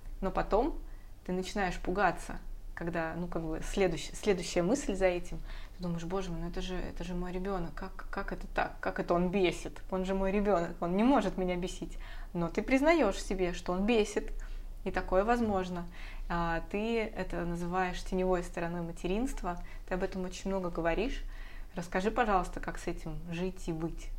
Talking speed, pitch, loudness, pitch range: 180 wpm, 180 Hz, -33 LUFS, 170-195 Hz